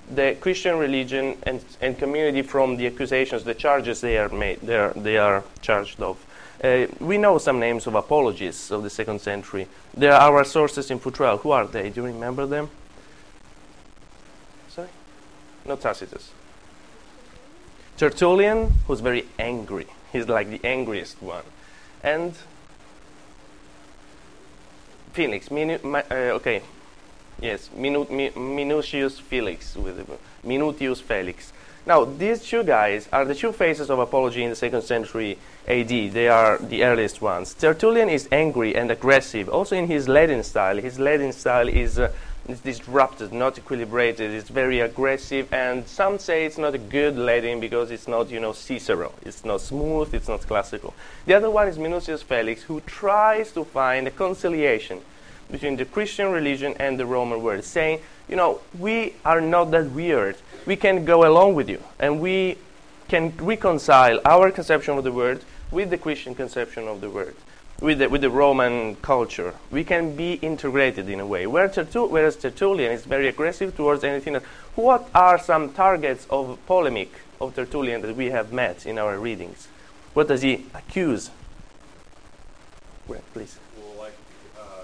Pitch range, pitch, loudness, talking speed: 120-160 Hz, 135 Hz, -22 LUFS, 160 wpm